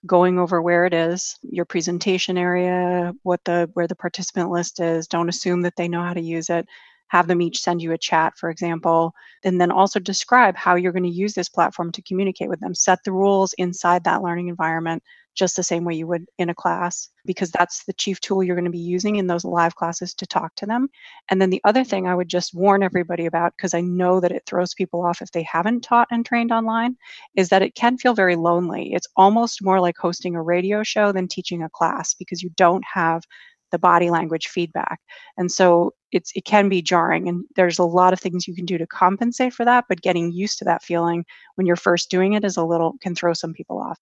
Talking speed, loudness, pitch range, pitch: 235 wpm, -20 LUFS, 175-190 Hz, 180 Hz